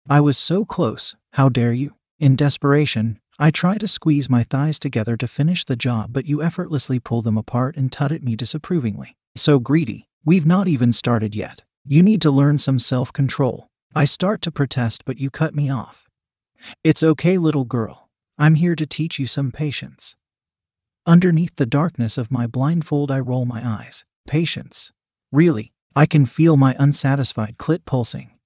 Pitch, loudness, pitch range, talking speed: 140 Hz, -19 LUFS, 125-155 Hz, 175 wpm